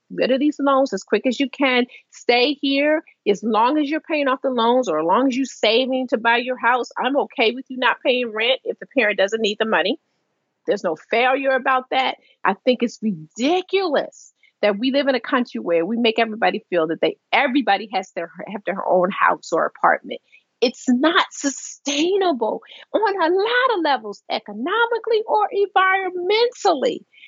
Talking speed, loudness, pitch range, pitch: 185 wpm, -20 LUFS, 225-310 Hz, 260 Hz